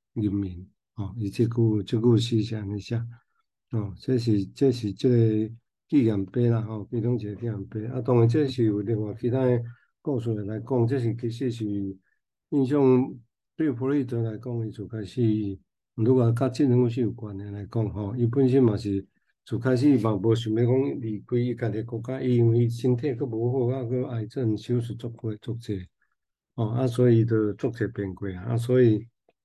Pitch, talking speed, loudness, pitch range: 115 Hz, 270 characters per minute, -26 LUFS, 105-125 Hz